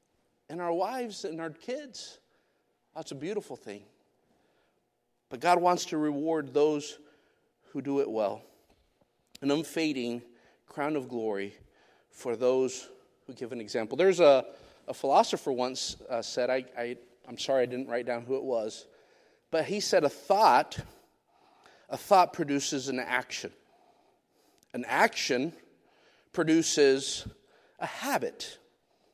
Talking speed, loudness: 130 wpm, -29 LUFS